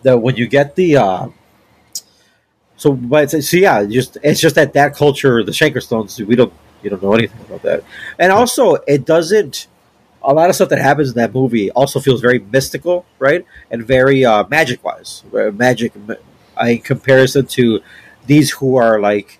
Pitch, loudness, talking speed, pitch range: 130 Hz, -13 LUFS, 180 wpm, 120-145 Hz